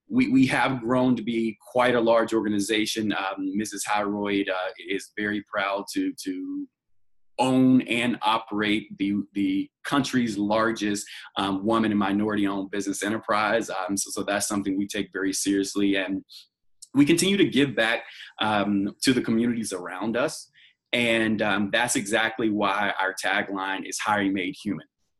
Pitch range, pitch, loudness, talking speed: 100-115 Hz, 105 Hz, -25 LUFS, 150 wpm